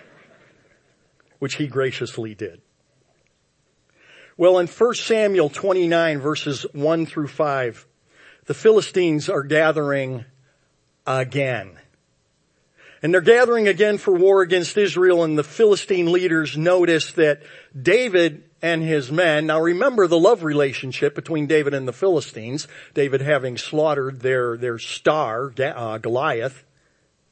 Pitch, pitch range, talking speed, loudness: 155 Hz, 135-180 Hz, 115 wpm, -20 LUFS